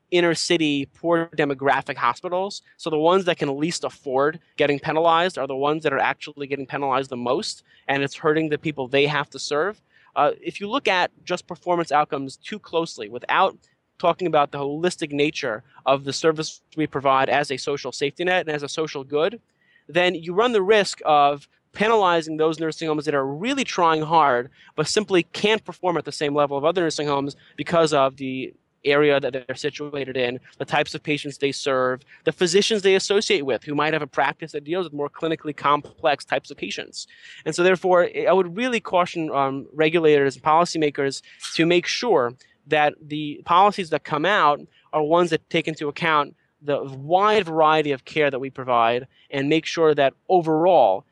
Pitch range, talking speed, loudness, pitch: 140-170 Hz, 190 wpm, -22 LUFS, 155 Hz